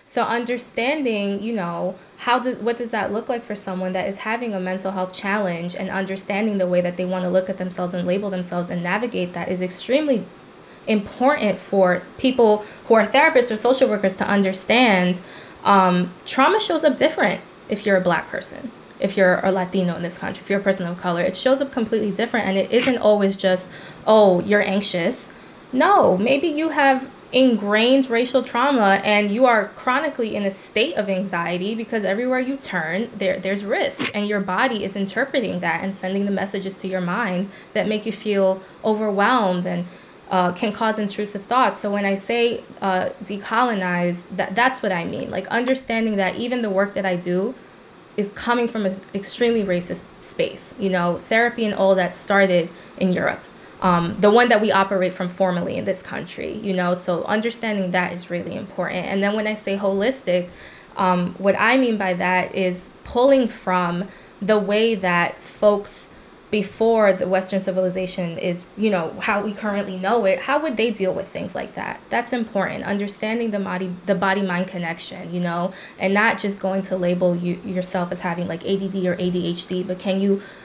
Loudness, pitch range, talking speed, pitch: -21 LUFS, 185-225 Hz, 190 wpm, 195 Hz